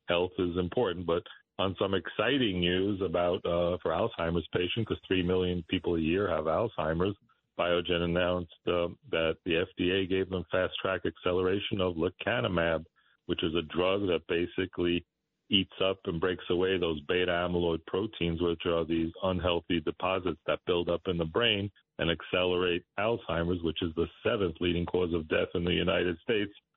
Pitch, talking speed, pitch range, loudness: 90 Hz, 170 wpm, 85-95 Hz, -30 LUFS